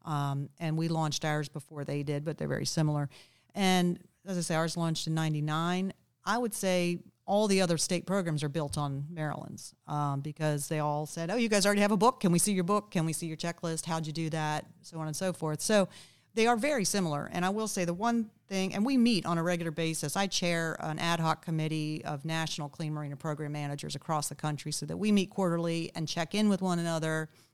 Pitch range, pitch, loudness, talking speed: 155-185 Hz, 165 Hz, -31 LUFS, 235 wpm